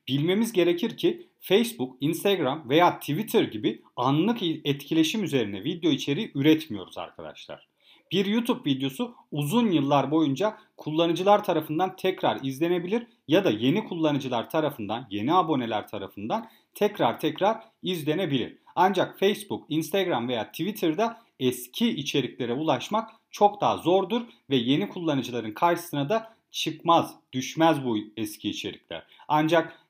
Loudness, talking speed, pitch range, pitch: -26 LUFS, 115 wpm, 140-200 Hz, 165 Hz